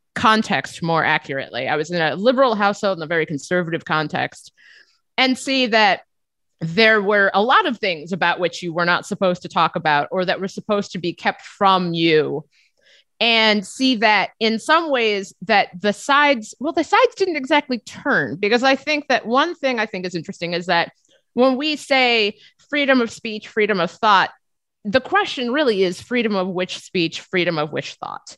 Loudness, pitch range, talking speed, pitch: -19 LUFS, 175-255 Hz, 190 wpm, 205 Hz